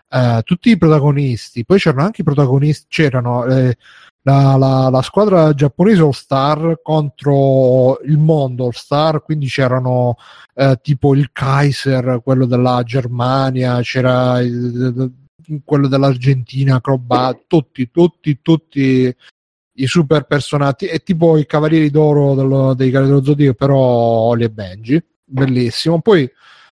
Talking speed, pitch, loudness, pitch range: 130 wpm, 135 Hz, -14 LUFS, 130-150 Hz